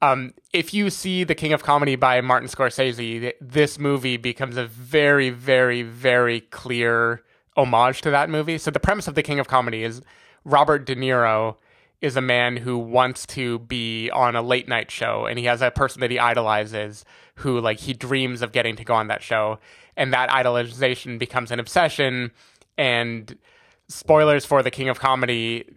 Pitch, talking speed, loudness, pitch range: 125 Hz, 185 wpm, -21 LUFS, 120-135 Hz